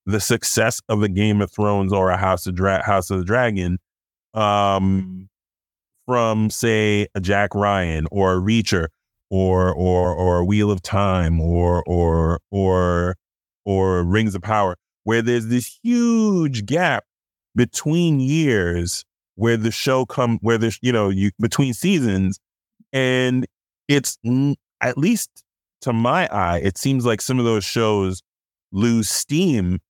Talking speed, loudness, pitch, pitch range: 145 wpm, -20 LUFS, 105 Hz, 95-120 Hz